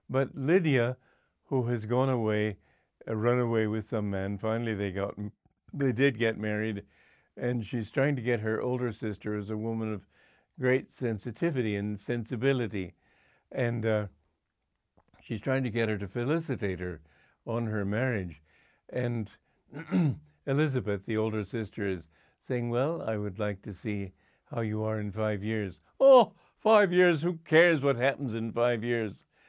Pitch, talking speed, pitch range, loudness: 115 Hz, 155 wpm, 105-130 Hz, -30 LUFS